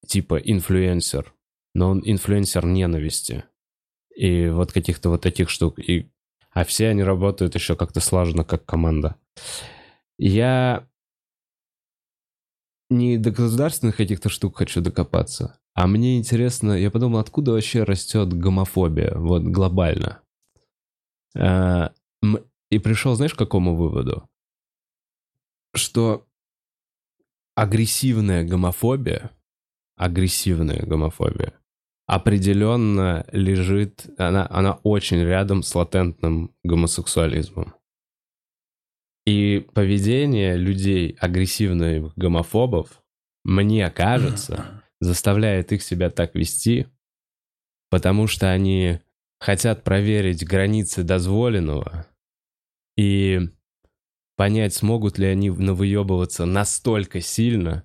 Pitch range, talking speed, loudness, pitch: 90-110 Hz, 90 wpm, -21 LUFS, 95 Hz